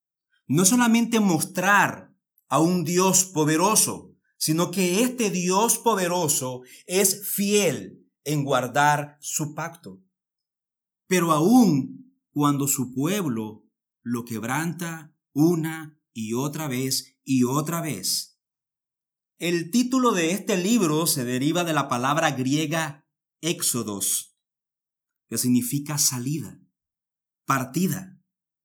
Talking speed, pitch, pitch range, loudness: 100 wpm, 160 Hz, 140-185 Hz, -23 LUFS